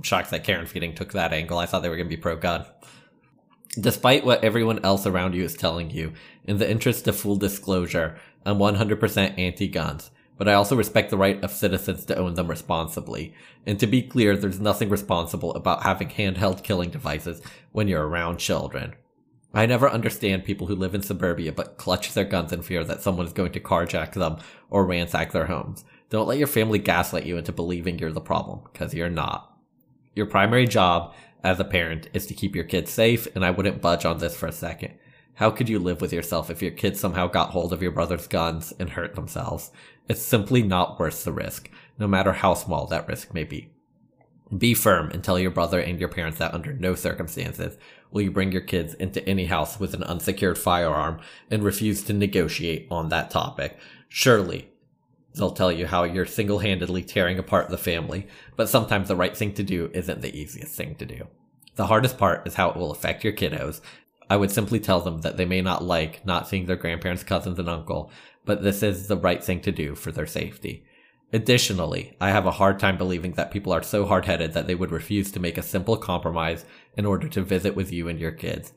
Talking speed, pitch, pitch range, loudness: 210 wpm, 95 Hz, 85-100 Hz, -24 LUFS